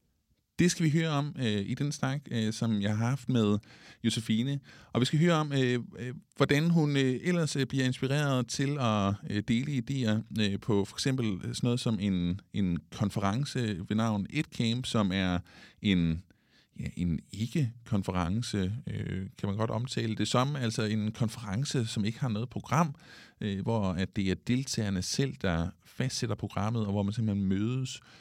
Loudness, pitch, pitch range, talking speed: -31 LUFS, 115 Hz, 100-130 Hz, 180 wpm